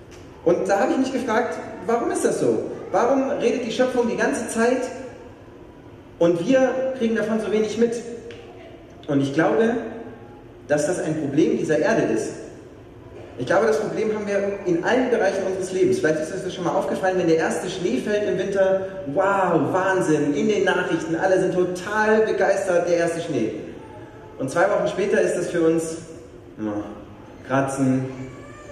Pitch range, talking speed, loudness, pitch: 160-225 Hz, 170 wpm, -22 LUFS, 190 Hz